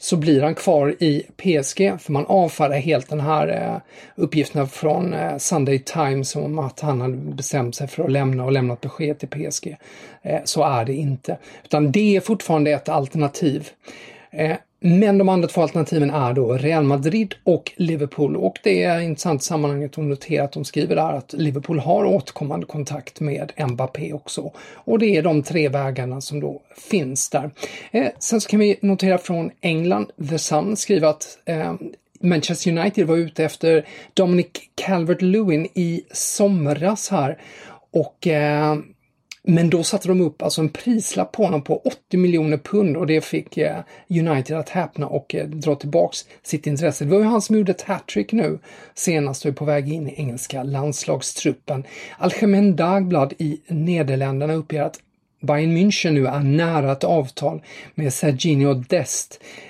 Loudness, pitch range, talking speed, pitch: -21 LUFS, 145-180 Hz, 165 wpm, 155 Hz